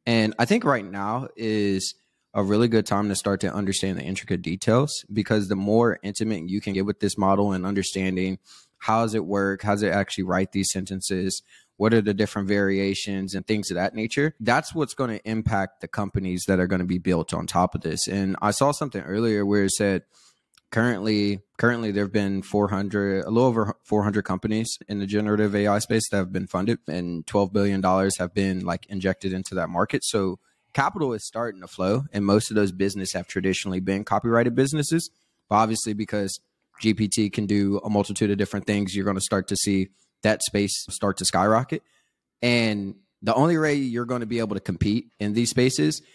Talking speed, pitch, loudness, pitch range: 205 wpm, 100 Hz, -24 LUFS, 95-110 Hz